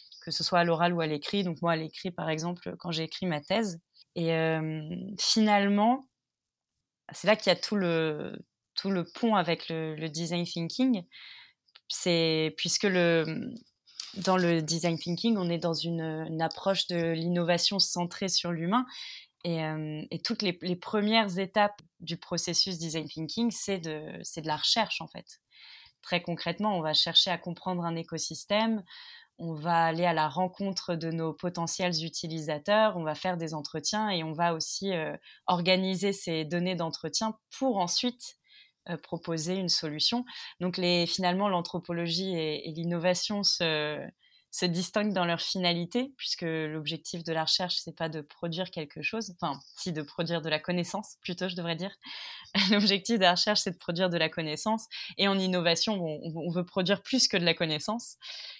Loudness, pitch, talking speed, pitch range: -29 LUFS, 175 Hz, 175 wpm, 165-195 Hz